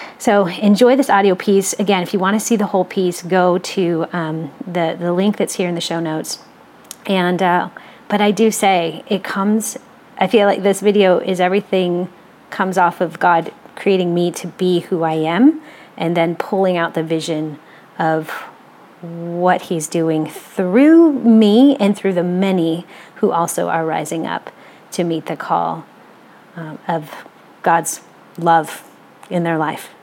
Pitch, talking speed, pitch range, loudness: 185 Hz, 170 wpm, 170-200 Hz, -16 LUFS